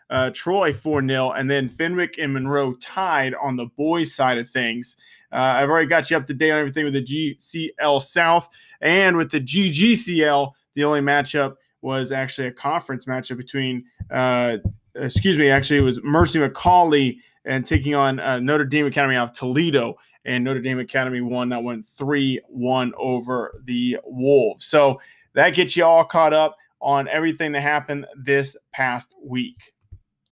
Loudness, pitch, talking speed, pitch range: -20 LUFS, 140 Hz, 170 wpm, 130-155 Hz